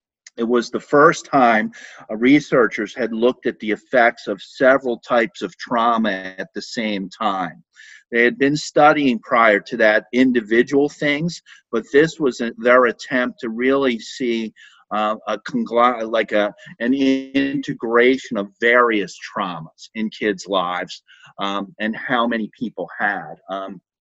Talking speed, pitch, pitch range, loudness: 140 wpm, 120 Hz, 105-130 Hz, -19 LUFS